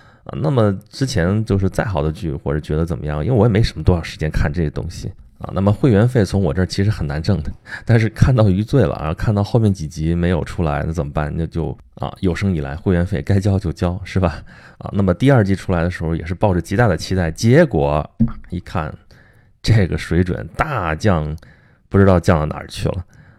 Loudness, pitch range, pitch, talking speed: -18 LUFS, 80-105 Hz, 95 Hz, 325 characters per minute